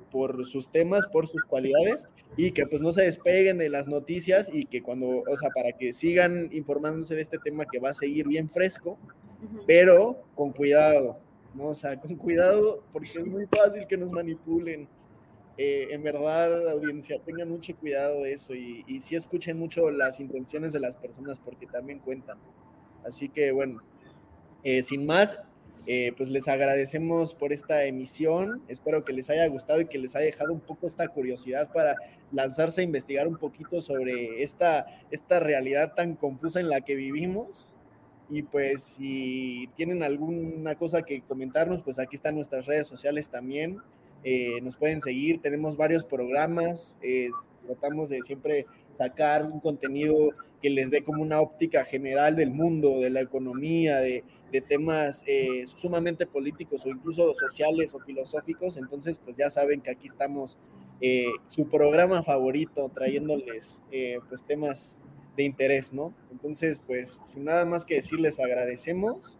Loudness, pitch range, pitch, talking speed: -27 LUFS, 135-165 Hz, 150 Hz, 165 wpm